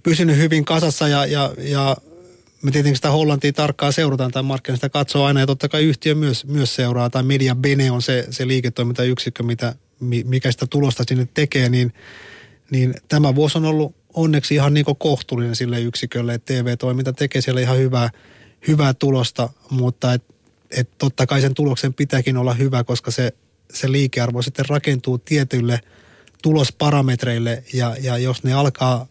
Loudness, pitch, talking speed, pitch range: -19 LUFS, 130 Hz, 165 wpm, 125-145 Hz